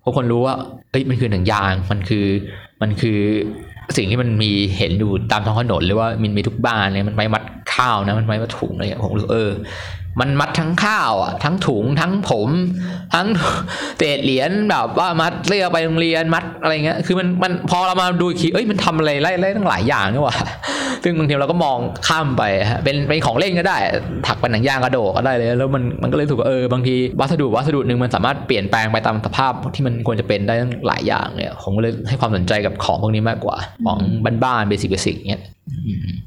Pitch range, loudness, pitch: 105-160 Hz, -18 LUFS, 125 Hz